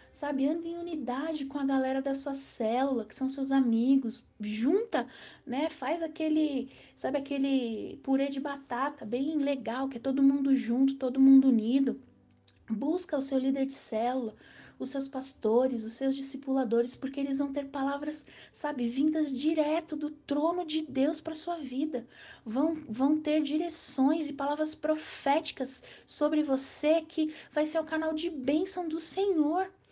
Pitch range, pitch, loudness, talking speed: 265-310 Hz, 280 Hz, -30 LUFS, 160 wpm